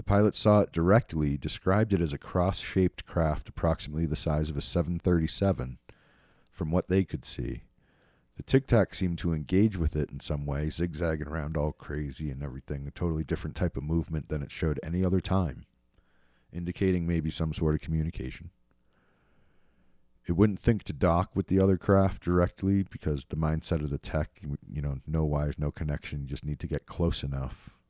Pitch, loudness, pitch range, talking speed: 80 Hz, -29 LUFS, 75-95 Hz, 185 wpm